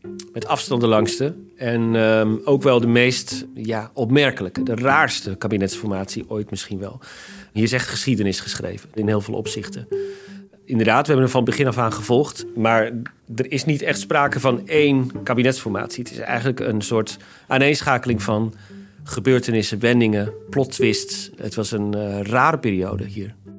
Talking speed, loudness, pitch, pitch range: 160 wpm, -20 LUFS, 115 Hz, 105-130 Hz